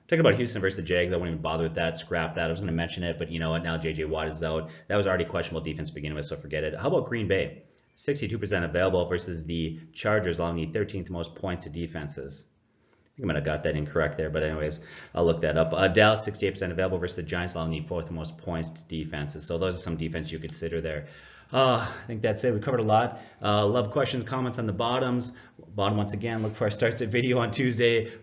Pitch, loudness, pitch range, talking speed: 90 Hz, -28 LUFS, 80-110 Hz, 260 wpm